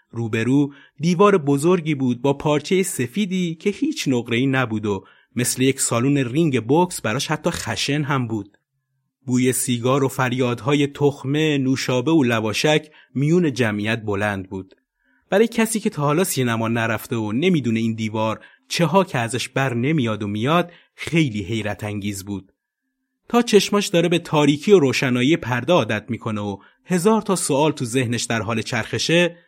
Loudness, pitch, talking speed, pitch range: -20 LUFS, 135 Hz, 155 wpm, 115-165 Hz